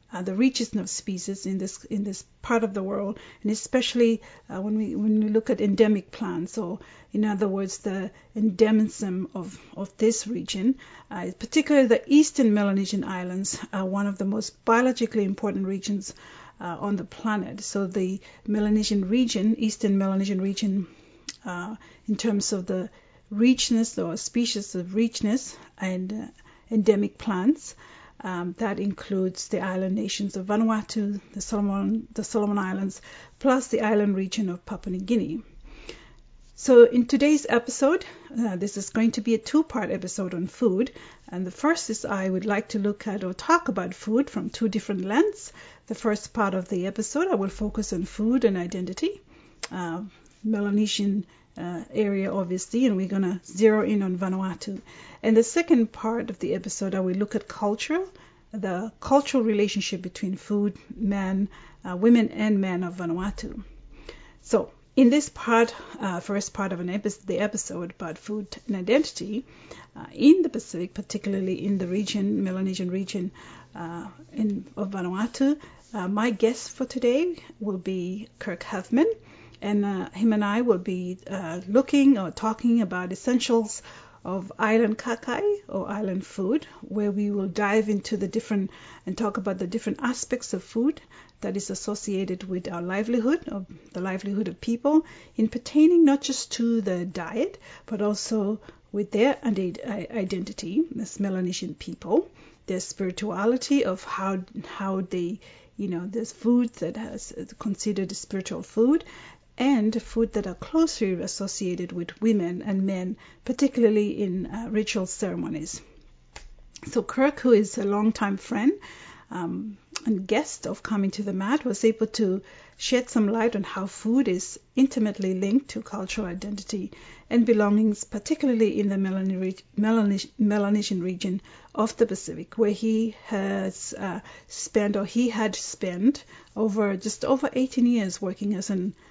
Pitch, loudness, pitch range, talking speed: 210 Hz, -26 LUFS, 195-230 Hz, 160 wpm